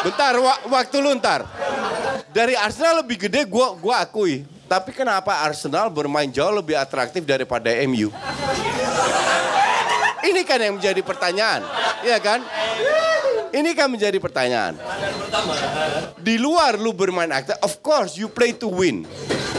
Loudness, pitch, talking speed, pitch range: -20 LUFS, 210 Hz, 130 wpm, 175-260 Hz